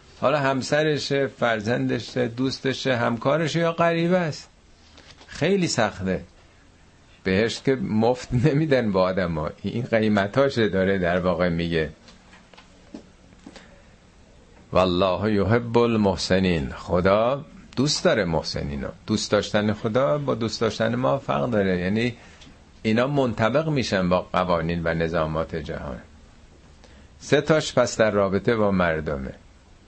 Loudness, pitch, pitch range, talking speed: -23 LUFS, 105 Hz, 85-125 Hz, 115 wpm